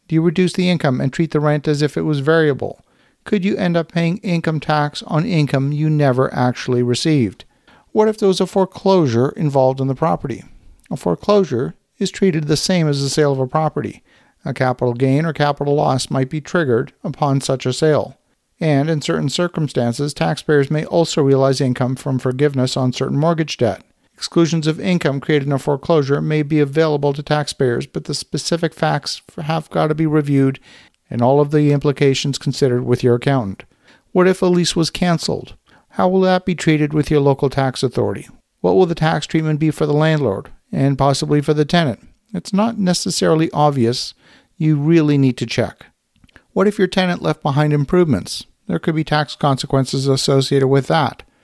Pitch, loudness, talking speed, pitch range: 150 Hz, -17 LUFS, 190 wpm, 135-170 Hz